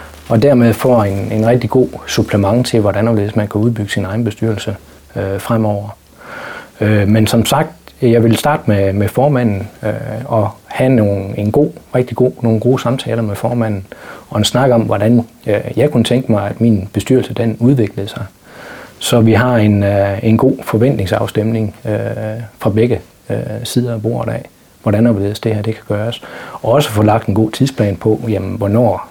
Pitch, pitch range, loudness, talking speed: 110 Hz, 105-120 Hz, -14 LUFS, 185 wpm